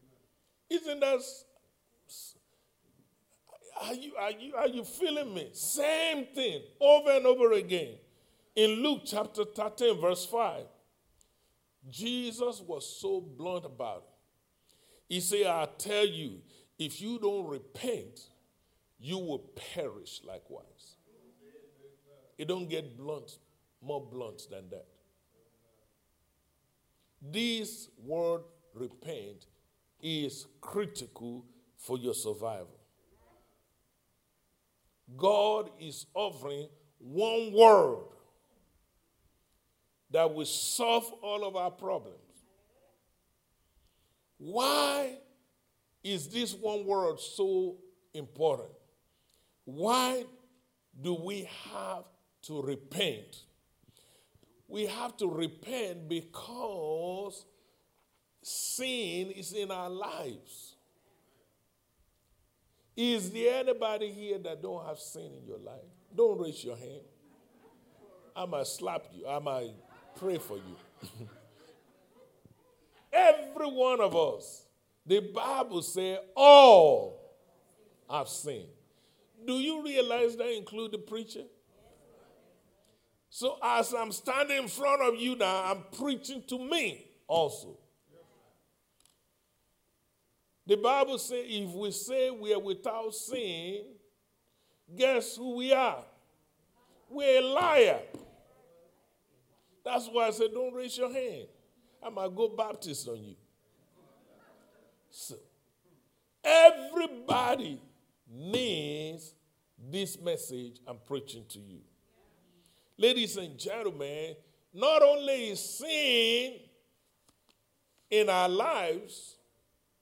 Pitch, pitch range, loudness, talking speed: 210 Hz, 155-255 Hz, -30 LUFS, 100 wpm